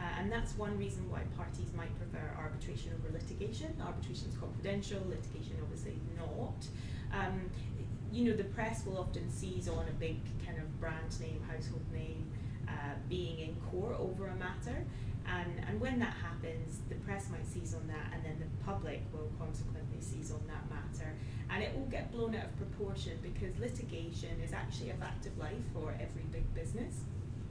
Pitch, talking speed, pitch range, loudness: 115 Hz, 180 wpm, 105-120 Hz, -41 LUFS